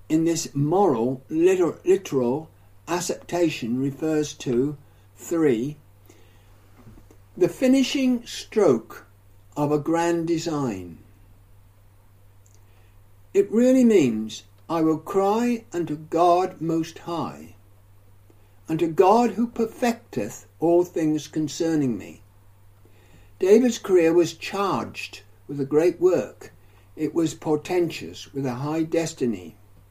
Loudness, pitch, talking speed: -23 LUFS, 140 Hz, 100 wpm